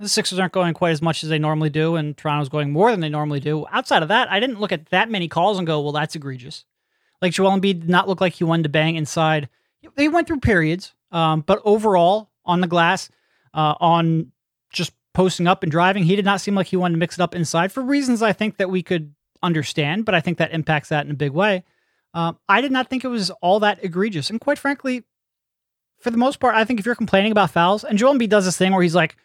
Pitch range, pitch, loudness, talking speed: 160-210 Hz, 180 Hz, -19 LUFS, 260 wpm